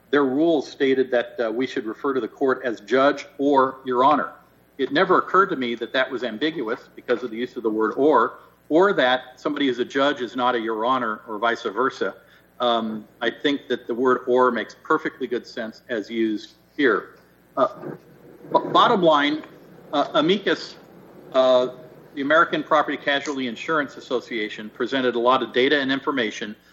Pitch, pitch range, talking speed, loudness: 125 Hz, 120-140 Hz, 180 wpm, -22 LUFS